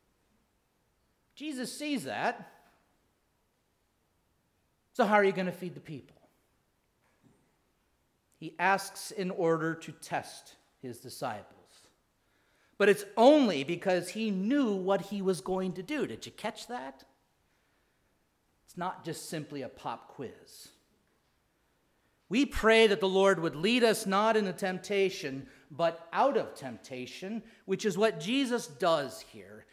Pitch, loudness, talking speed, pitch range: 195 Hz, -30 LUFS, 130 wpm, 170-220 Hz